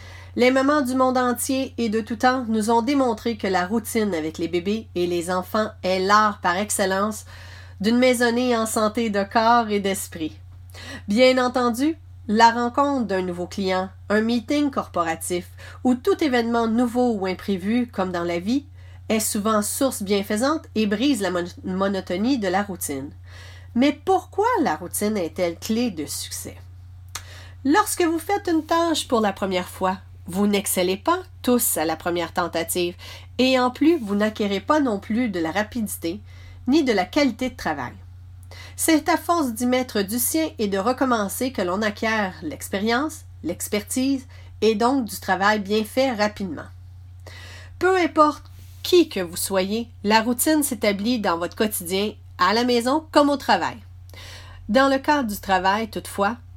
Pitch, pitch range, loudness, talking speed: 210 Hz, 175-250 Hz, -22 LUFS, 160 wpm